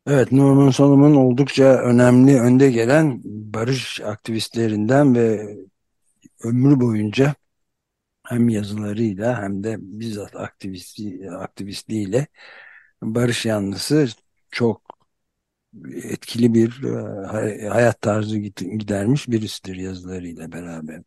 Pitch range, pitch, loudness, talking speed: 100-125 Hz, 110 Hz, -18 LUFS, 85 wpm